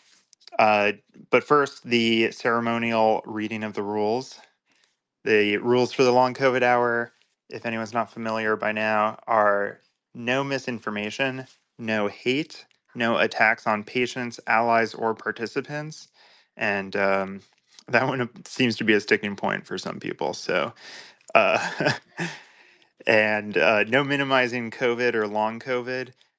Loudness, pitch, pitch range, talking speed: -24 LUFS, 115 Hz, 110-125 Hz, 130 wpm